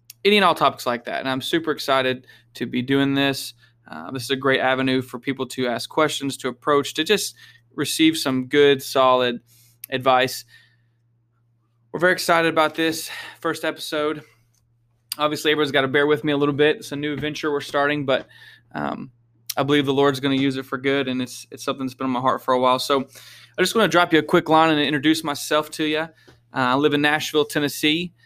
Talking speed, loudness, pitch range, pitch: 215 wpm, -21 LUFS, 125-150 Hz, 140 Hz